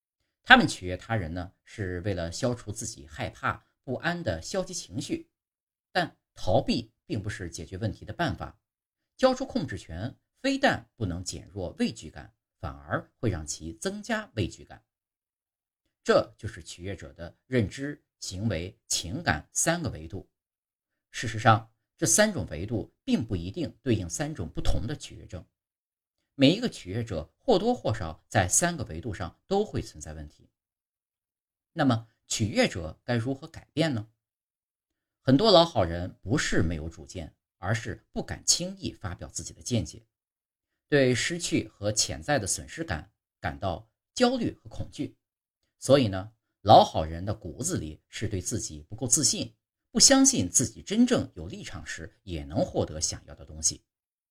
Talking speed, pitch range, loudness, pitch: 235 characters per minute, 90-130 Hz, -27 LUFS, 110 Hz